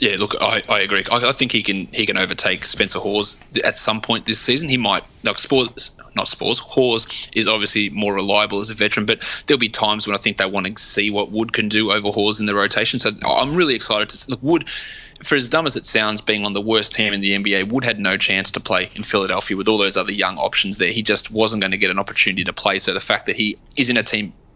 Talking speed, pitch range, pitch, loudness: 265 wpm, 100-110 Hz, 105 Hz, -17 LUFS